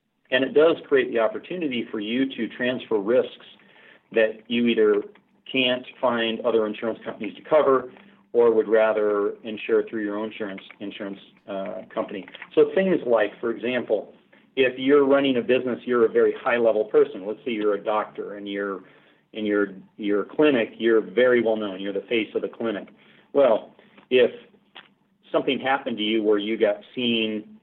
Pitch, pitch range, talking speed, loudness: 120 Hz, 105-150 Hz, 170 wpm, -23 LUFS